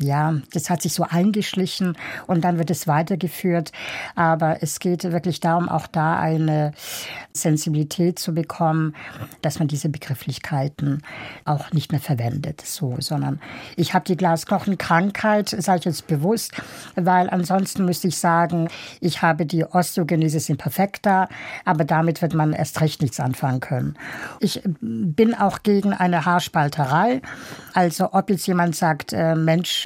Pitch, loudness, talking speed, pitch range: 165 Hz, -22 LUFS, 145 wpm, 155-180 Hz